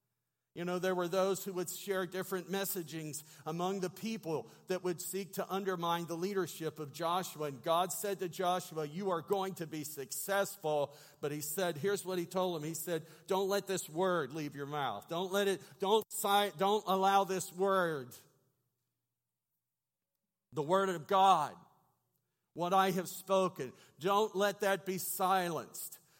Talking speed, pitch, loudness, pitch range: 165 wpm, 180 Hz, -35 LUFS, 160-195 Hz